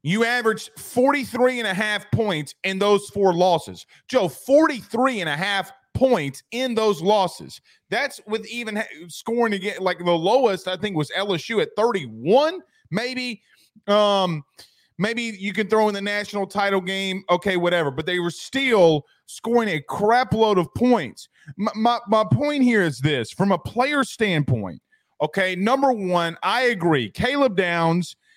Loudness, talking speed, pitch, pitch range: -21 LUFS, 160 wpm, 205 Hz, 180-240 Hz